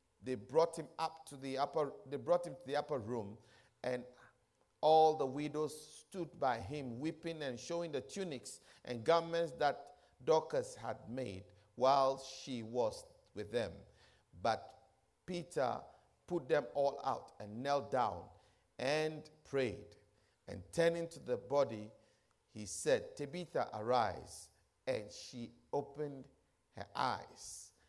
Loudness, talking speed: -38 LUFS, 135 wpm